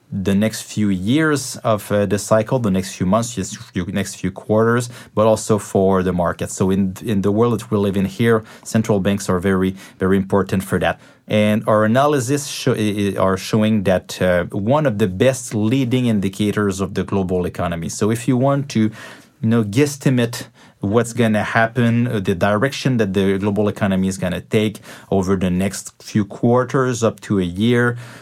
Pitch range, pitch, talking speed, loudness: 95-115 Hz, 105 Hz, 185 wpm, -18 LUFS